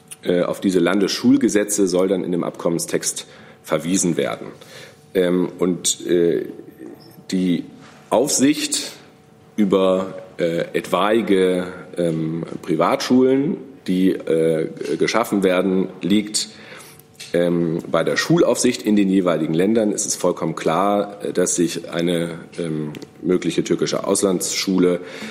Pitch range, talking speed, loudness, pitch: 85-100 Hz, 90 wpm, -19 LUFS, 90 Hz